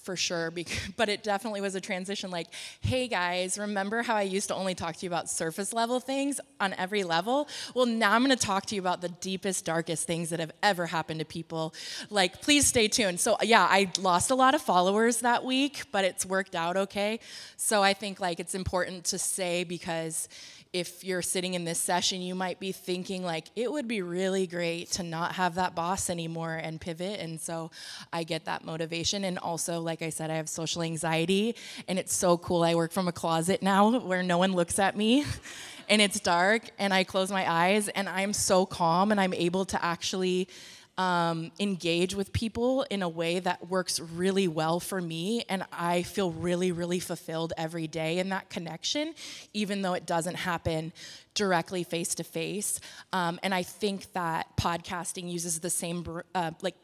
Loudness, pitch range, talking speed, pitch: -29 LUFS, 170-200 Hz, 200 wpm, 185 Hz